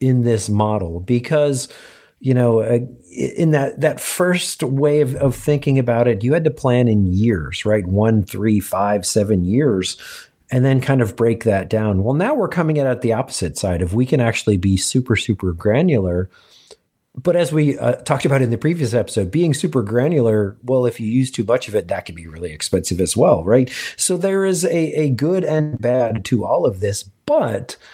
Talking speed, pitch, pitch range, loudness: 200 wpm, 120 Hz, 105-145 Hz, -18 LUFS